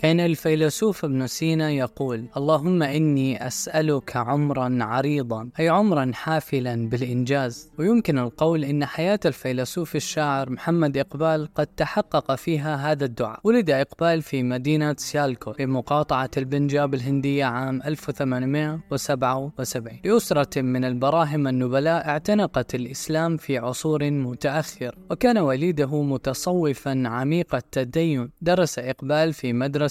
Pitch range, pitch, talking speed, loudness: 130-160 Hz, 145 Hz, 110 wpm, -23 LUFS